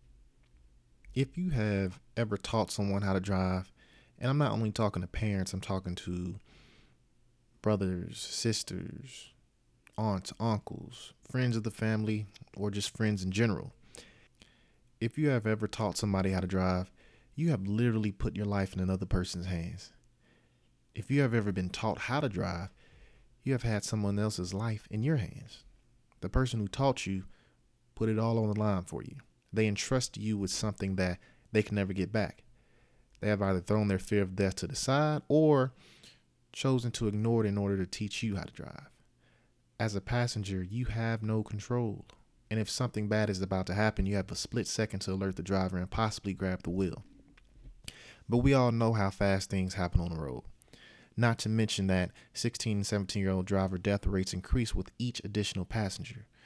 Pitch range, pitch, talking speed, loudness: 95-115 Hz, 105 Hz, 185 wpm, -33 LUFS